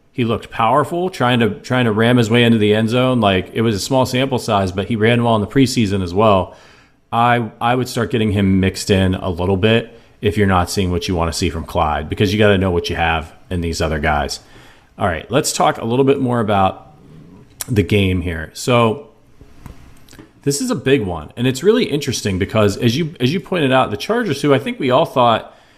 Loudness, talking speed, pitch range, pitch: -16 LUFS, 235 wpm, 95-125 Hz, 115 Hz